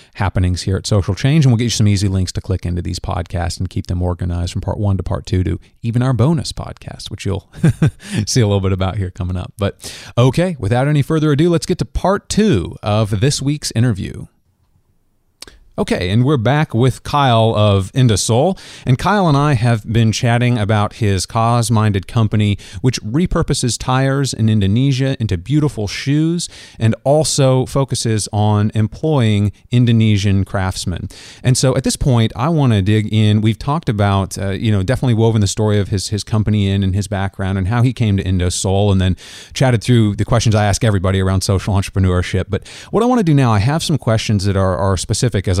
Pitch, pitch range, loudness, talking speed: 110 Hz, 100-130 Hz, -16 LUFS, 200 wpm